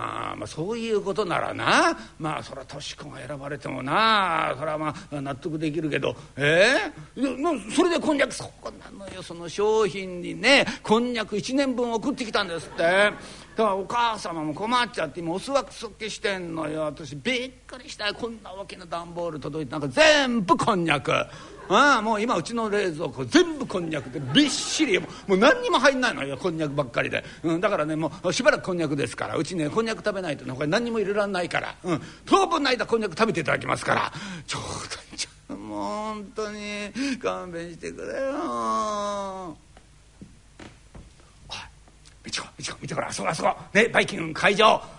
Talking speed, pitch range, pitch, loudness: 380 characters per minute, 155-230 Hz, 195 Hz, -24 LUFS